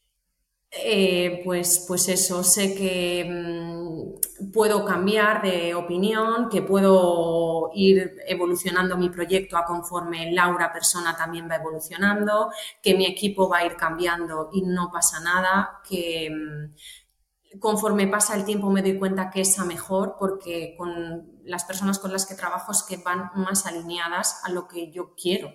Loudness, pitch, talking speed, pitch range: -23 LUFS, 180 Hz, 155 wpm, 170-195 Hz